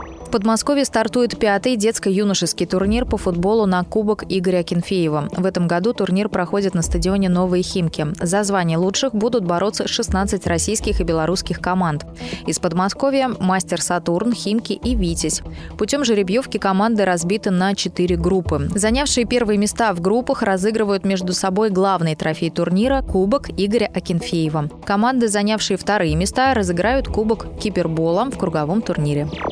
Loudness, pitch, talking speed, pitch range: -19 LUFS, 195 Hz, 140 wpm, 180-220 Hz